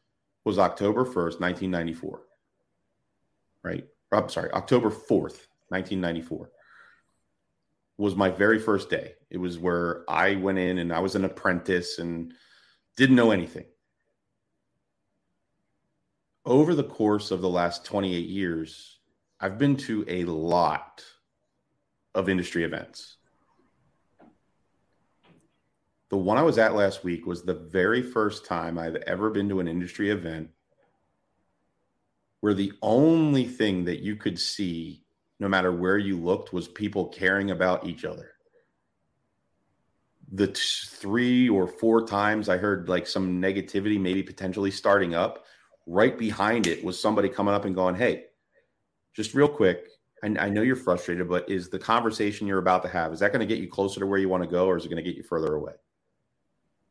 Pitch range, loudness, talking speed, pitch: 90-105 Hz, -26 LUFS, 155 wpm, 95 Hz